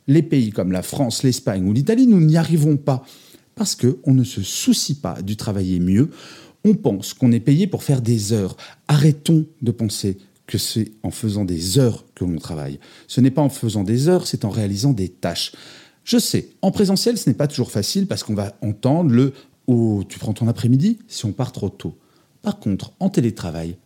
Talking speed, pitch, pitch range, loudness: 205 wpm, 125 Hz, 105-150 Hz, -19 LUFS